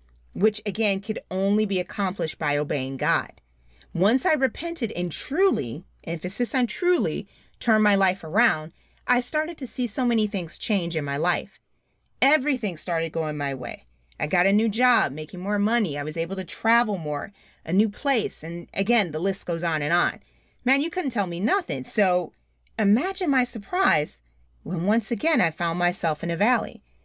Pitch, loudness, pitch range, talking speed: 200 Hz, -24 LUFS, 165-240 Hz, 180 wpm